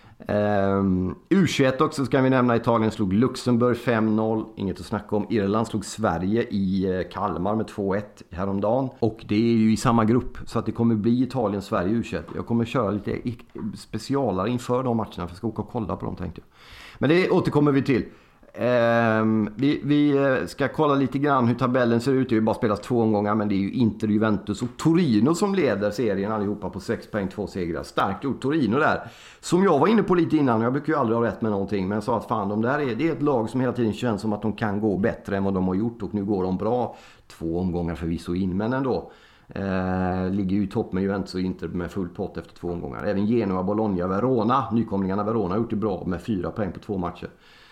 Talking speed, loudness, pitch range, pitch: 230 wpm, -24 LUFS, 100-120 Hz, 110 Hz